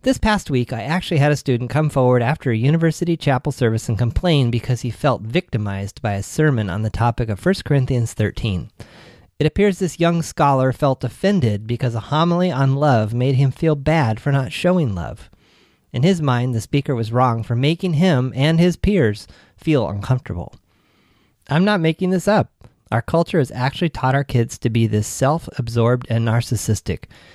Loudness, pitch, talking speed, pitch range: -19 LUFS, 130 Hz, 185 wpm, 115-160 Hz